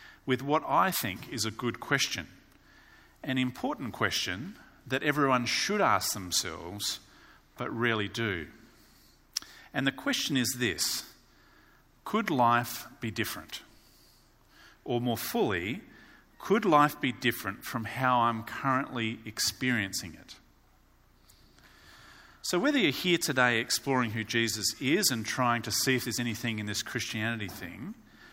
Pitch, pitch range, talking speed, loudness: 120 Hz, 110-130 Hz, 130 wpm, -29 LUFS